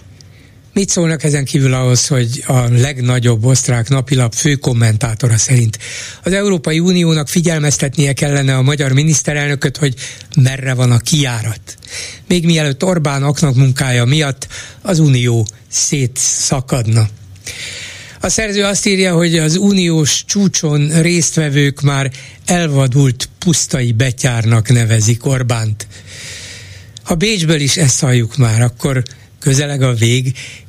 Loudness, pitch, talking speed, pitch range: -13 LUFS, 135 Hz, 115 wpm, 120-155 Hz